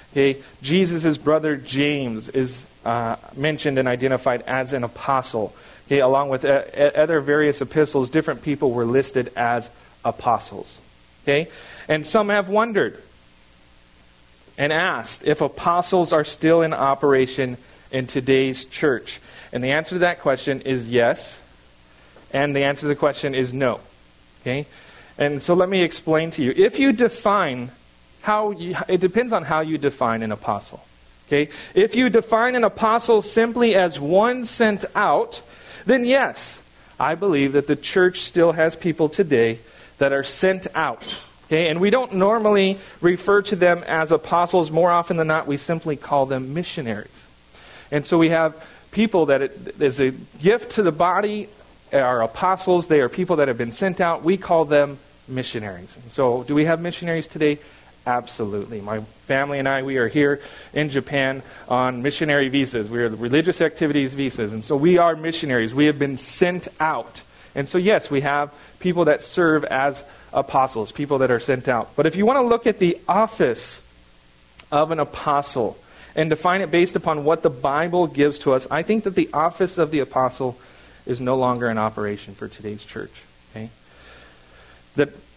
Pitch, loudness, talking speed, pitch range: 145 Hz, -20 LUFS, 170 wpm, 125-175 Hz